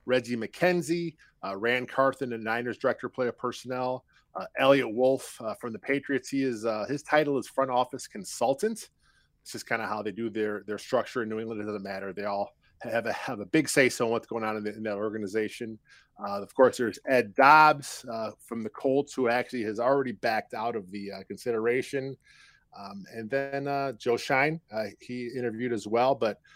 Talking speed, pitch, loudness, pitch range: 210 wpm, 120 Hz, -28 LUFS, 110-135 Hz